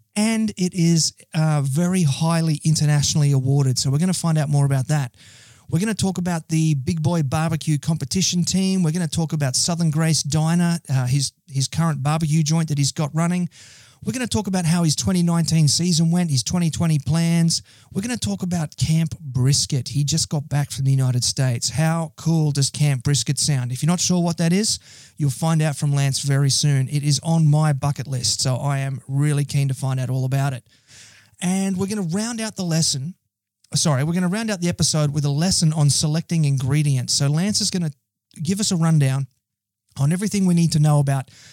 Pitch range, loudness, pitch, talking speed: 135-170 Hz, -20 LUFS, 155 Hz, 215 wpm